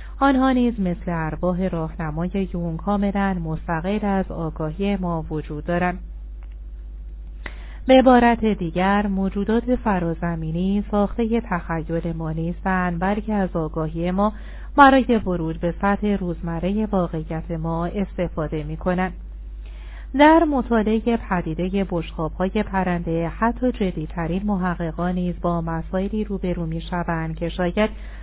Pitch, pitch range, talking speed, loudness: 180 Hz, 165-205 Hz, 110 wpm, -22 LUFS